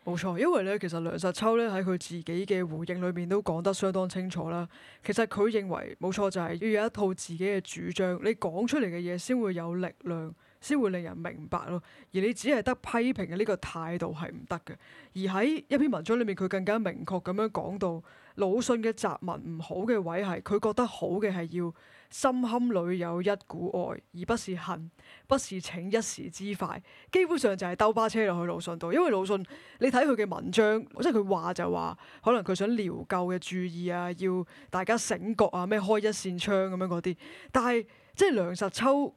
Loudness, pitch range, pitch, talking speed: -30 LUFS, 175-220 Hz, 190 Hz, 295 characters per minute